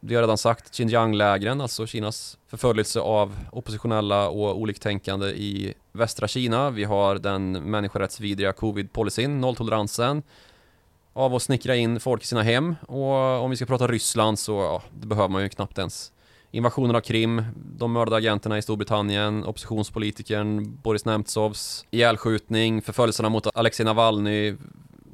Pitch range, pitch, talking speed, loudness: 105-120 Hz, 110 Hz, 140 wpm, -24 LUFS